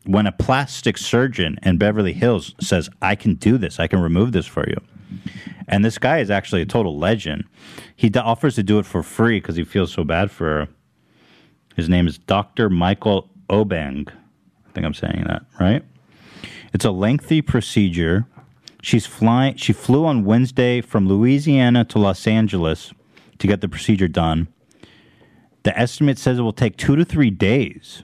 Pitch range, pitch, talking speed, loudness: 90-120 Hz, 105 Hz, 180 wpm, -19 LUFS